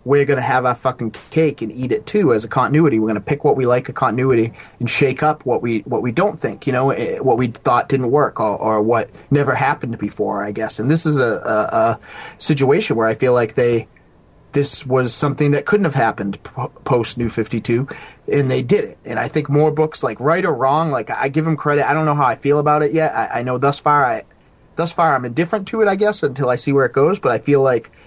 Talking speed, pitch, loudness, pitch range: 255 wpm, 135 Hz, -17 LUFS, 120-150 Hz